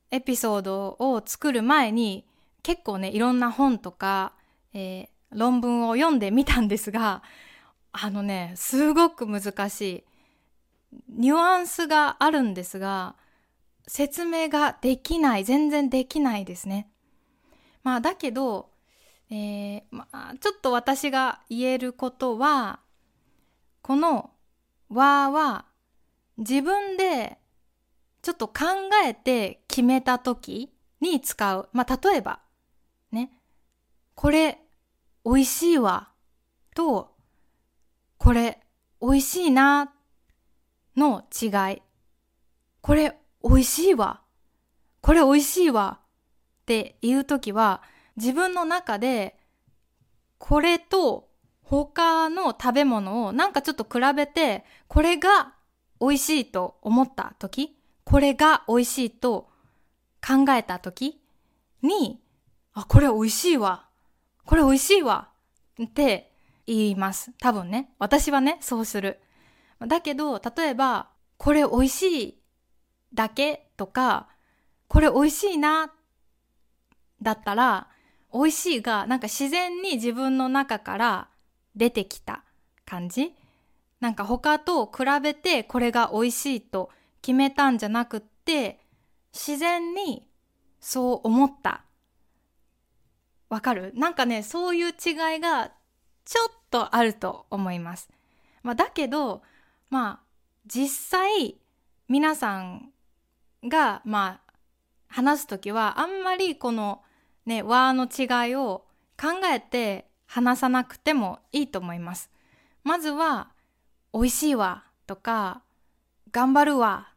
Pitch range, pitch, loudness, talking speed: 225-300 Hz, 260 Hz, -24 LUFS, 210 characters per minute